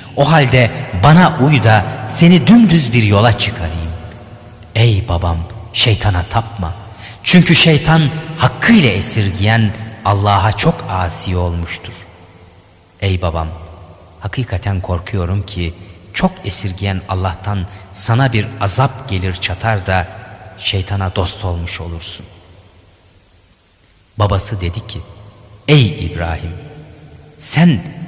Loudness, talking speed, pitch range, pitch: -14 LUFS, 100 wpm, 90-115 Hz, 100 Hz